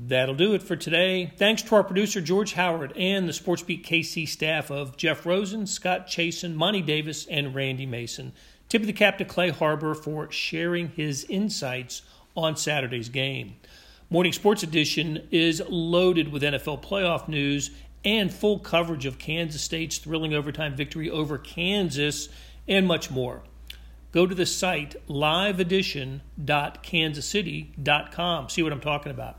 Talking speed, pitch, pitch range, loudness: 150 wpm, 160 Hz, 145-180 Hz, -25 LUFS